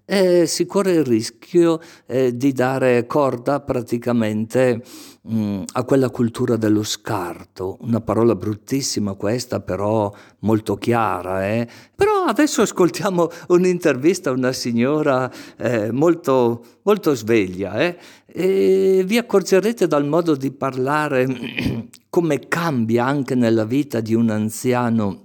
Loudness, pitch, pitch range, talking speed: -19 LUFS, 130 Hz, 115-165 Hz, 120 wpm